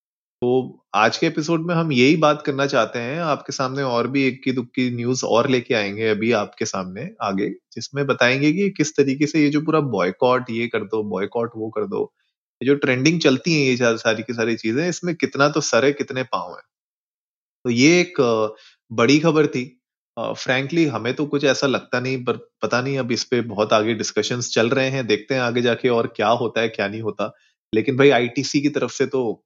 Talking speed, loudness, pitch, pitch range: 215 wpm, -20 LUFS, 130 Hz, 115-140 Hz